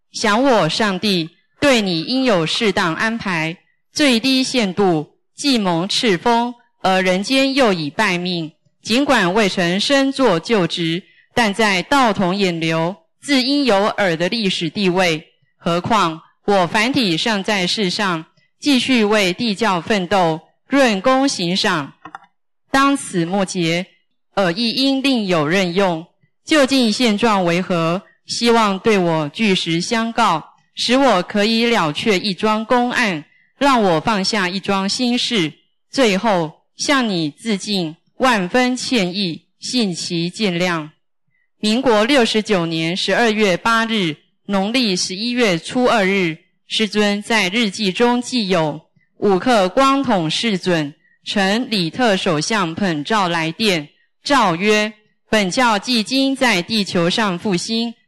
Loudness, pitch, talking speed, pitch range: -17 LUFS, 205 Hz, 185 characters per minute, 175-235 Hz